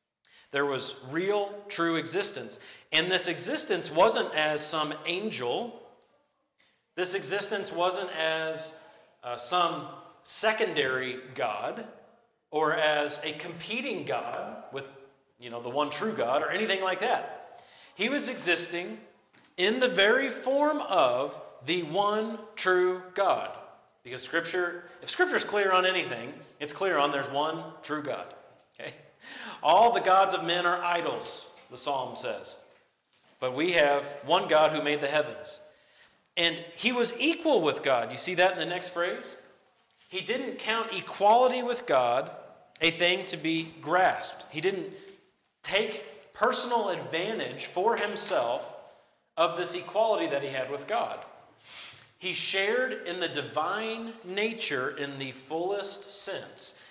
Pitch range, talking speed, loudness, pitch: 155-220 Hz, 140 wpm, -28 LUFS, 180 Hz